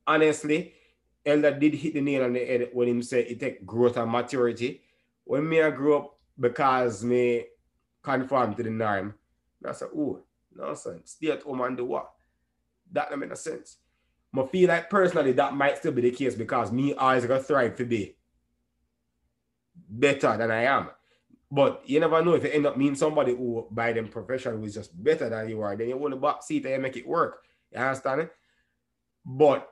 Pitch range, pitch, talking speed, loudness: 115-145 Hz, 125 Hz, 205 wpm, -26 LUFS